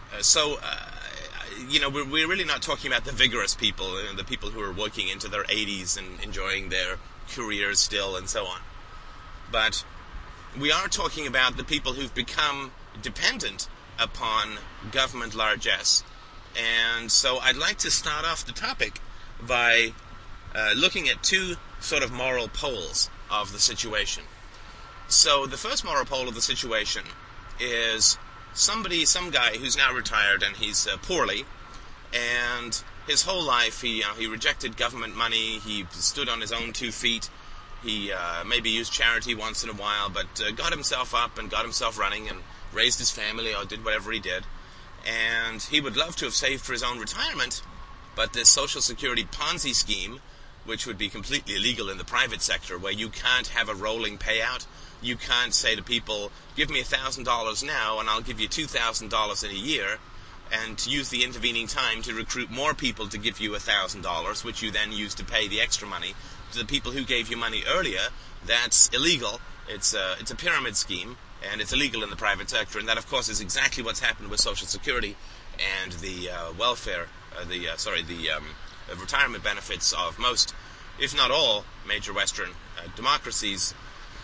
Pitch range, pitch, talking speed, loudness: 100-120 Hz, 110 Hz, 185 wpm, -25 LUFS